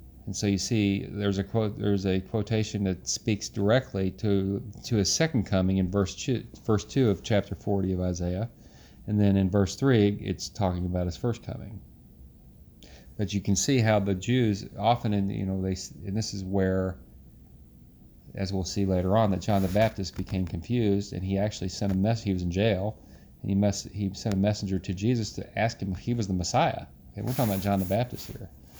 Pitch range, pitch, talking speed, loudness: 95-110 Hz, 100 Hz, 210 wpm, -28 LUFS